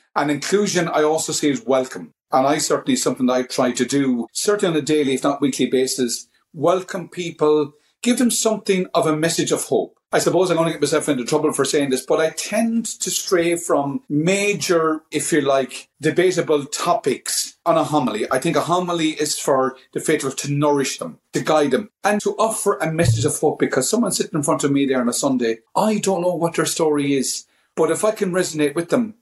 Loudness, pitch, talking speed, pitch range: -20 LUFS, 155 Hz, 220 wpm, 140-180 Hz